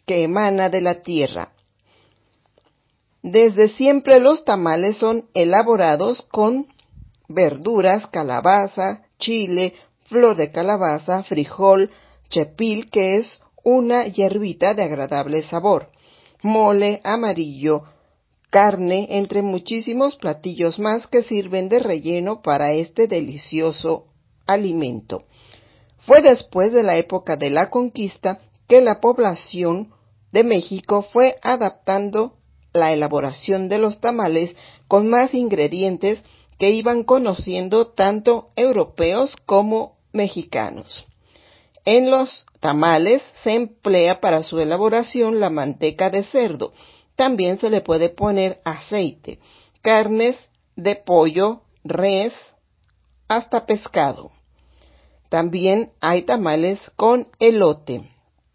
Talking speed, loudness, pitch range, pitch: 105 wpm, -18 LUFS, 165-225 Hz, 195 Hz